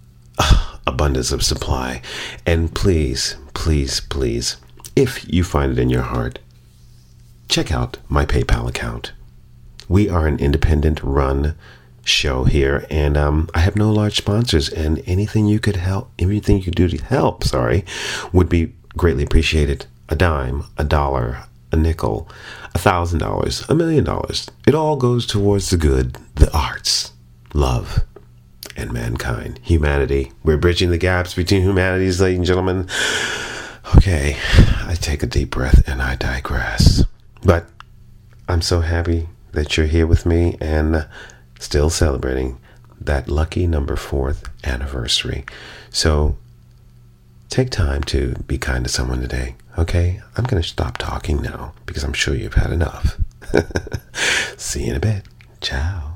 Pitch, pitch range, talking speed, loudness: 80 Hz, 70-95 Hz, 145 wpm, -19 LUFS